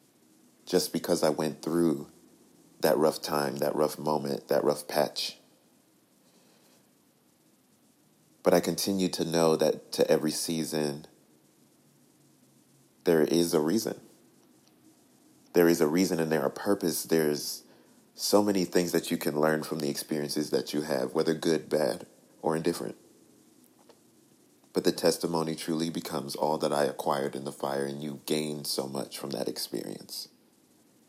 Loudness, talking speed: -29 LUFS, 145 wpm